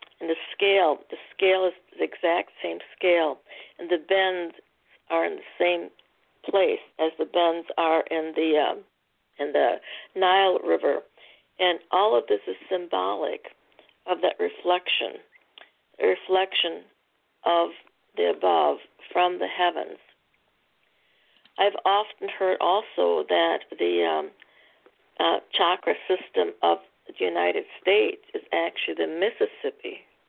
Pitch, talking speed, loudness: 185 Hz, 125 wpm, -25 LUFS